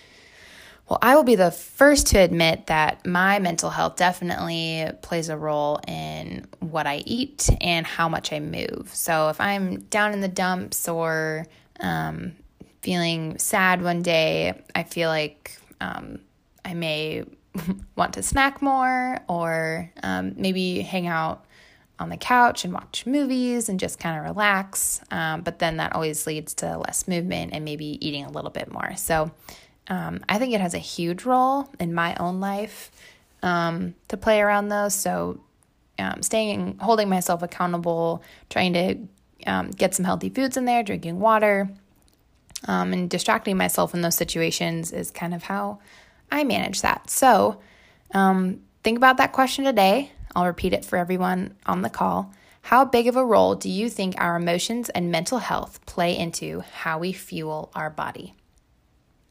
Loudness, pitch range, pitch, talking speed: -23 LUFS, 160-200 Hz, 175 Hz, 165 wpm